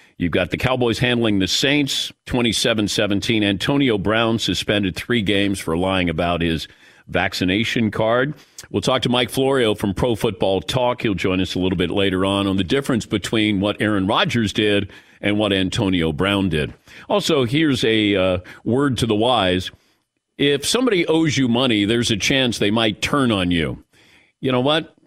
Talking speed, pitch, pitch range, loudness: 175 wpm, 105 Hz, 95-125 Hz, -19 LUFS